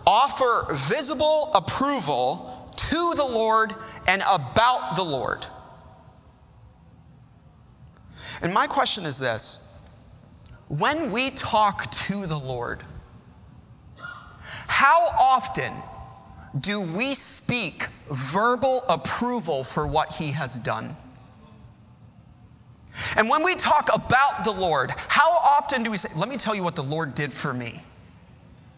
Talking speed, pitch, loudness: 115 wpm, 200 Hz, -23 LUFS